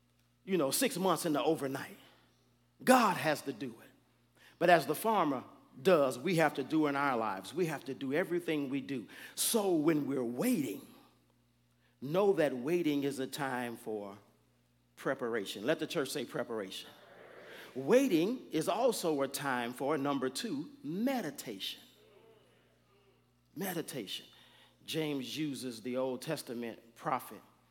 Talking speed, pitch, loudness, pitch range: 140 wpm, 140 Hz, -34 LUFS, 120-160 Hz